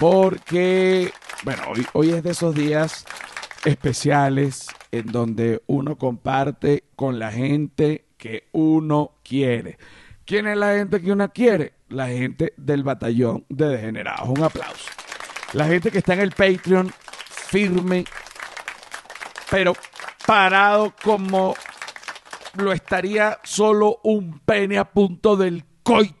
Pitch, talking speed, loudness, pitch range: 165 Hz, 125 wpm, -20 LUFS, 140-195 Hz